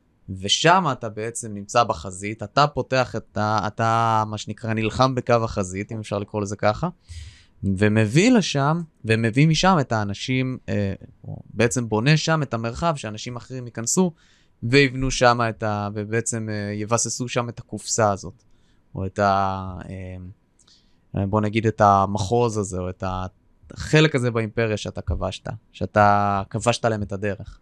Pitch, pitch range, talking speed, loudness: 110 Hz, 100-125 Hz, 140 wpm, -22 LUFS